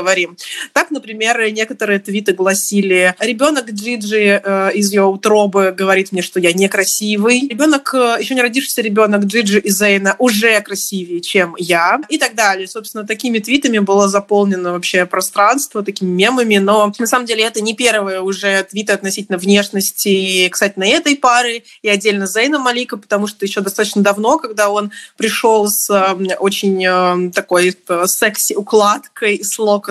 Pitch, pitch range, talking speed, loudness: 205 Hz, 195-225 Hz, 150 wpm, -14 LUFS